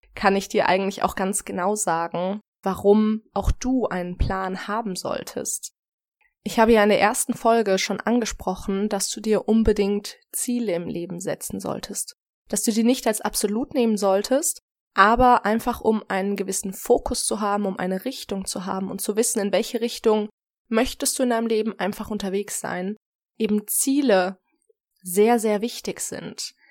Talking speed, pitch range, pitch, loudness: 165 wpm, 195-235 Hz, 210 Hz, -23 LUFS